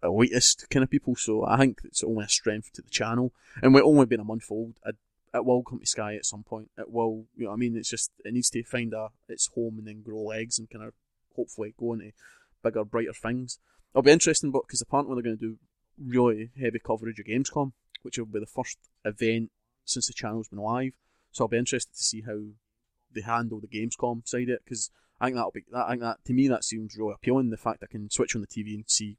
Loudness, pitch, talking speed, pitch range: -27 LUFS, 115 Hz, 245 wpm, 110-125 Hz